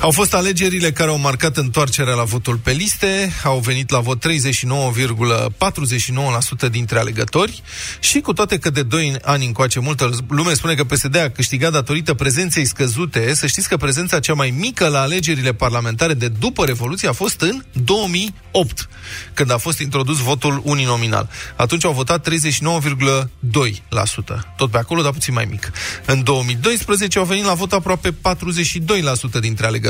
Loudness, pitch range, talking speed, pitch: -17 LUFS, 125-170 Hz, 160 wpm, 140 Hz